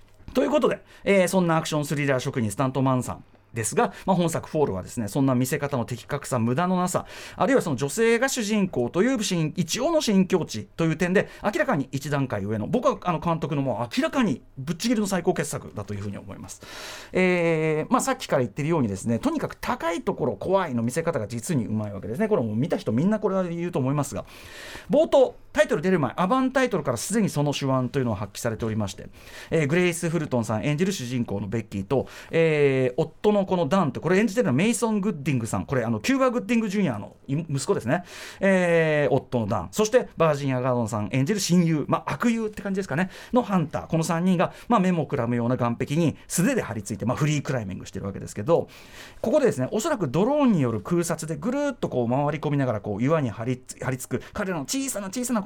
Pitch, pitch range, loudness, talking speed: 155 Hz, 125-195 Hz, -25 LUFS, 485 characters per minute